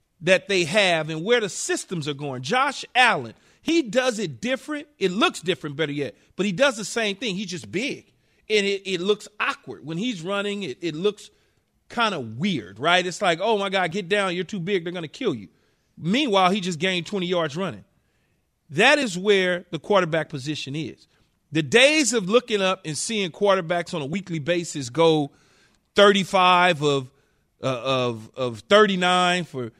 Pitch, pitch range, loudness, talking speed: 185 Hz, 160-210 Hz, -22 LUFS, 185 wpm